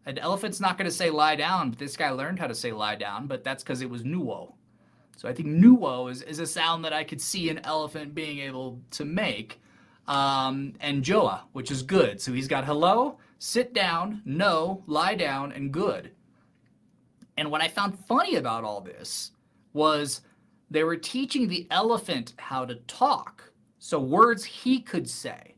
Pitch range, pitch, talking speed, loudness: 135-190 Hz, 155 Hz, 185 wpm, -27 LUFS